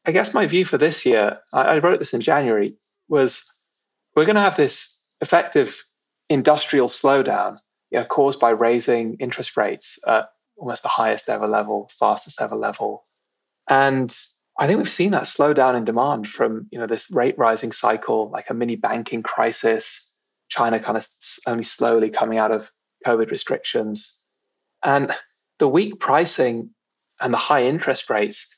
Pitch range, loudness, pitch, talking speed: 115-135 Hz, -20 LUFS, 120 Hz, 160 wpm